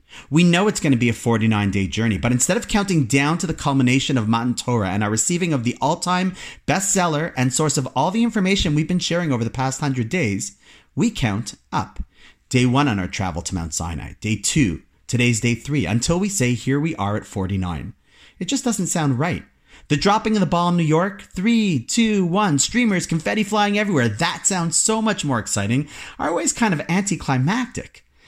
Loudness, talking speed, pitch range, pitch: -20 LUFS, 205 wpm, 115-180 Hz, 145 Hz